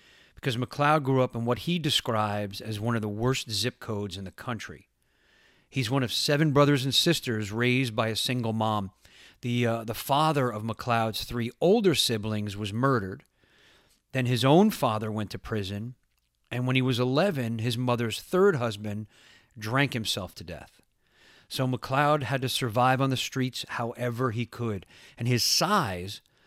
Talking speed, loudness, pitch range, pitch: 170 wpm, -27 LUFS, 110-130 Hz, 120 Hz